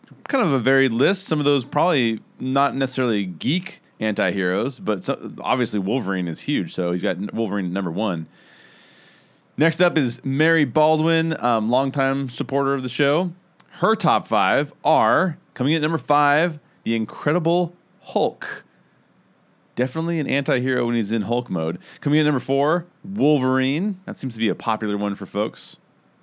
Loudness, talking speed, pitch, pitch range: -21 LUFS, 160 wpm, 135 Hz, 115-155 Hz